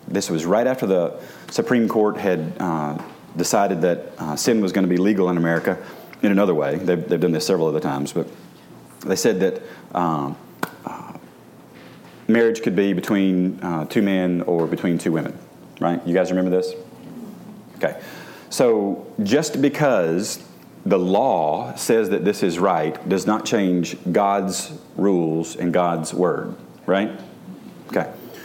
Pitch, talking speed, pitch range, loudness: 90 Hz, 155 wpm, 85-100 Hz, -21 LUFS